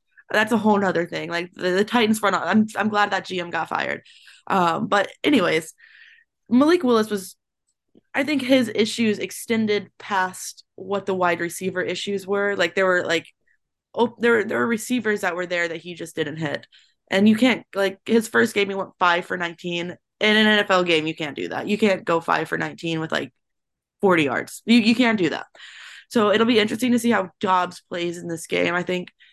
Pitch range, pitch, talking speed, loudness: 175-220 Hz, 200 Hz, 210 wpm, -21 LUFS